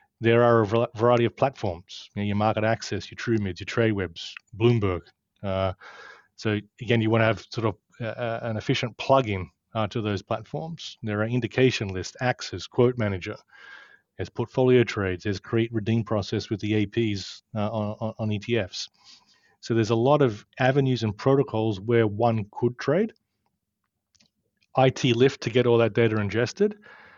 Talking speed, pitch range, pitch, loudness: 170 wpm, 105-120 Hz, 115 Hz, -25 LUFS